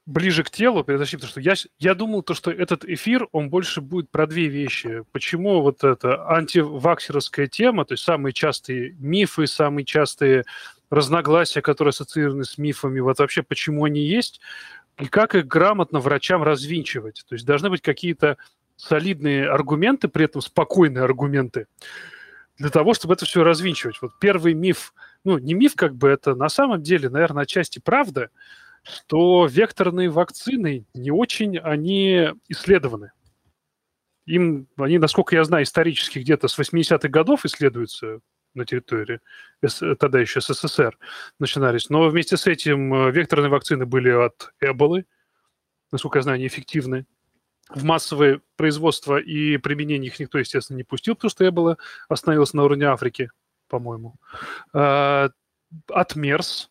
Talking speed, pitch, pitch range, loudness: 145 wpm, 155 Hz, 140-175 Hz, -20 LUFS